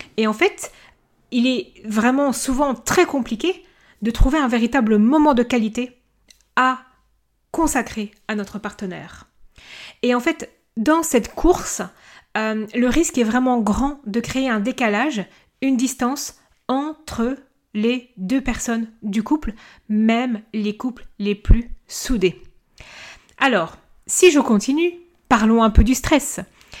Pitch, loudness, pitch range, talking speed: 245 Hz, -20 LUFS, 220-275 Hz, 135 wpm